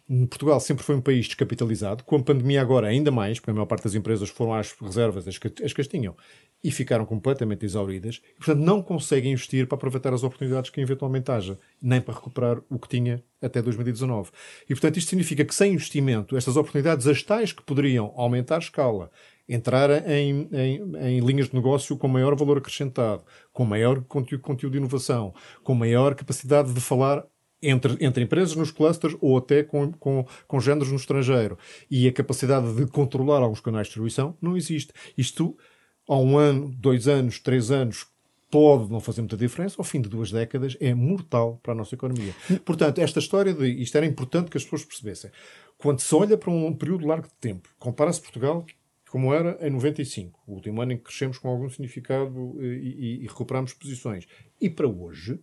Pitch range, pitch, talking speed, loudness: 120-145 Hz, 135 Hz, 195 wpm, -24 LUFS